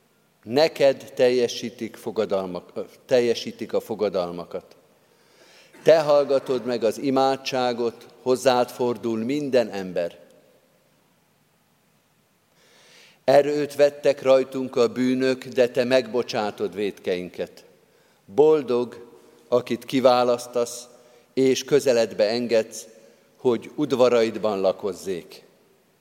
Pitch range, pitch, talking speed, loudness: 120-135 Hz, 125 Hz, 75 wpm, -23 LUFS